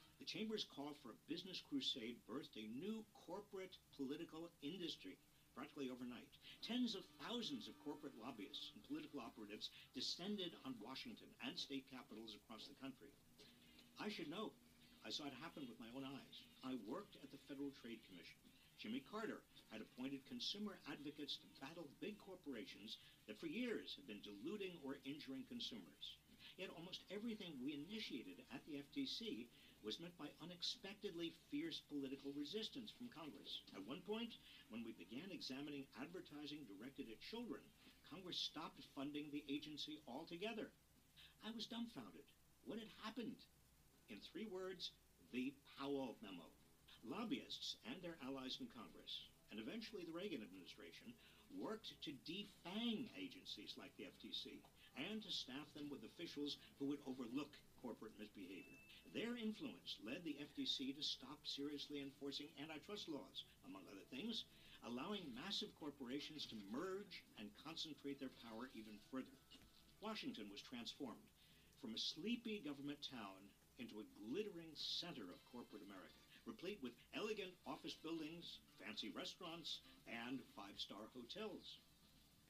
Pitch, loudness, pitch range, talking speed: 160 Hz, -52 LUFS, 140-220 Hz, 140 wpm